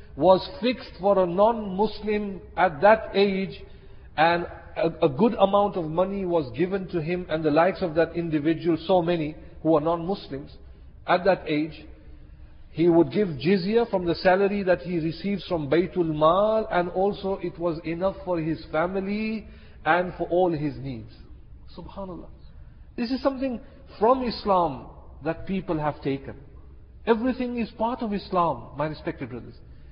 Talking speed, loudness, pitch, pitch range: 155 wpm, -25 LUFS, 175 Hz, 155-200 Hz